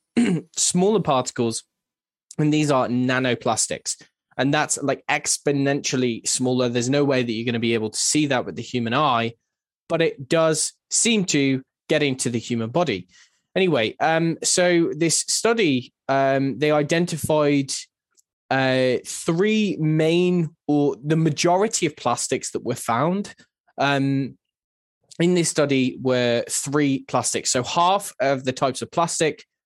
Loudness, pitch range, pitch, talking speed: -21 LUFS, 125-165 Hz, 145 Hz, 140 wpm